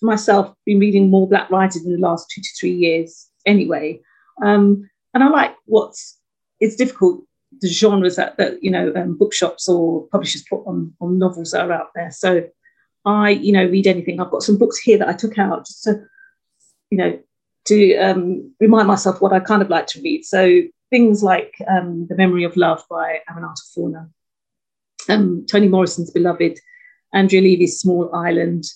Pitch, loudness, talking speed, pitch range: 190 Hz, -16 LUFS, 185 wpm, 175-210 Hz